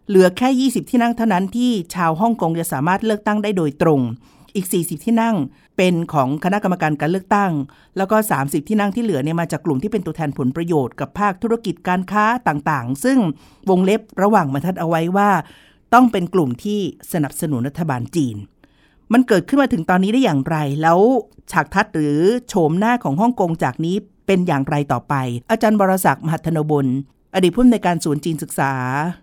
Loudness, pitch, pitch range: -18 LUFS, 180 Hz, 155-210 Hz